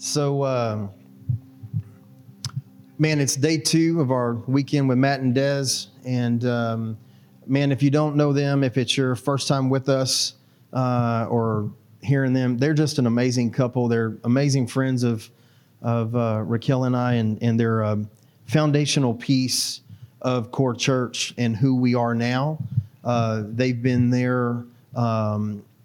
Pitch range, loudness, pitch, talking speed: 115-135 Hz, -22 LUFS, 125 Hz, 150 wpm